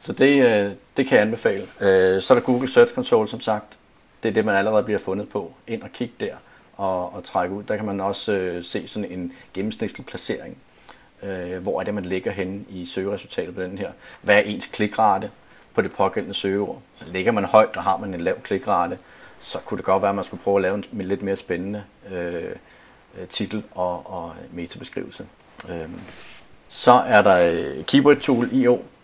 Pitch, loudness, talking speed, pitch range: 100 Hz, -22 LUFS, 200 wpm, 95-105 Hz